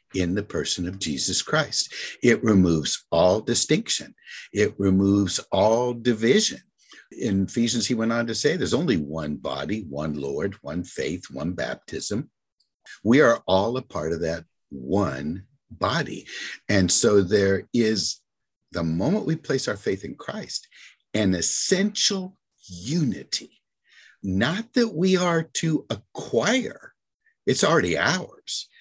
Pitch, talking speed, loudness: 110 Hz, 135 wpm, -24 LUFS